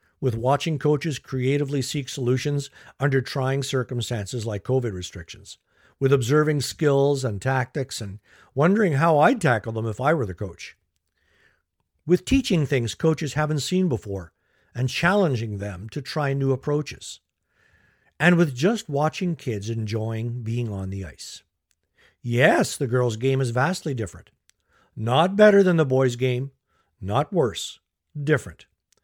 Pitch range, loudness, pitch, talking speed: 115-150 Hz, -23 LUFS, 130 Hz, 140 wpm